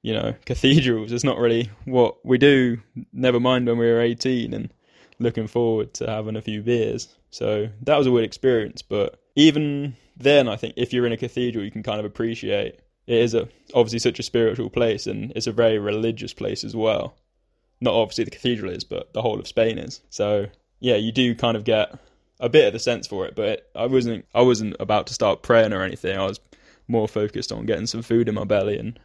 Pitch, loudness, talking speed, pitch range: 115 Hz, -22 LUFS, 225 wpm, 110-125 Hz